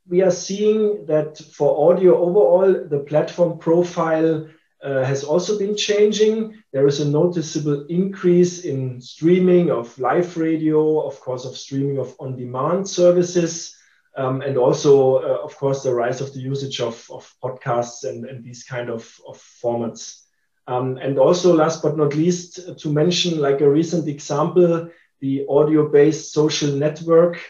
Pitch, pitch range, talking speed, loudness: 155 Hz, 135-175 Hz, 155 wpm, -19 LUFS